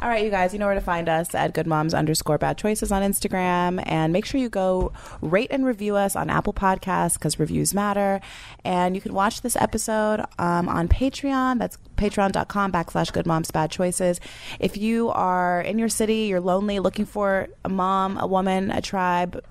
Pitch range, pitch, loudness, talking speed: 175-210 Hz, 190 Hz, -23 LUFS, 200 wpm